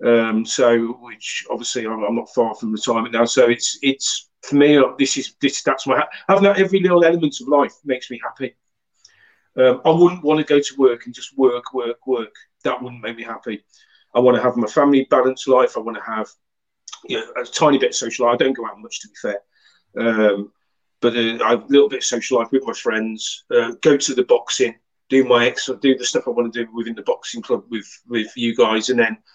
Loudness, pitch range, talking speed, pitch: -18 LUFS, 115-145 Hz, 240 wpm, 125 Hz